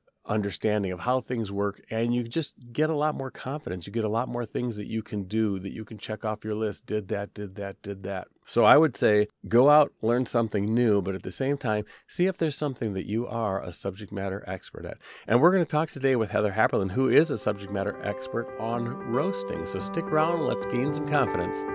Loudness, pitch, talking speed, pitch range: -27 LUFS, 110 Hz, 235 wpm, 100-130 Hz